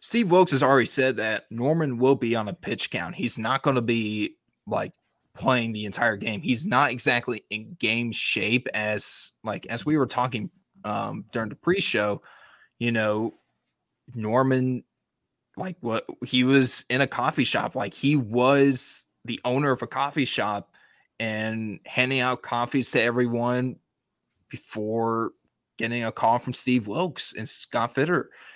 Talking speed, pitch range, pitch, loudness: 160 wpm, 115-135 Hz, 125 Hz, -25 LUFS